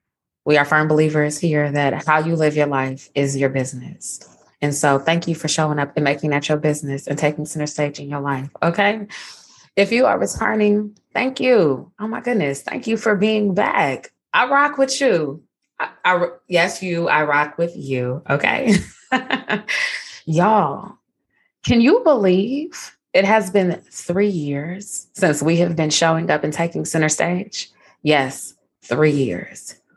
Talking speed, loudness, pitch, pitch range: 165 wpm, -19 LUFS, 160 Hz, 145-205 Hz